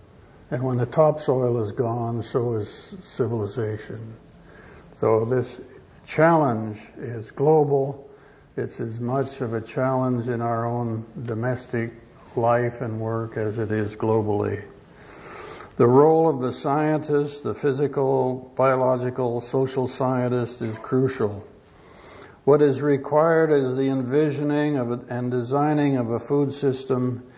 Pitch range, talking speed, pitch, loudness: 115-140 Hz, 125 wpm, 125 Hz, -23 LUFS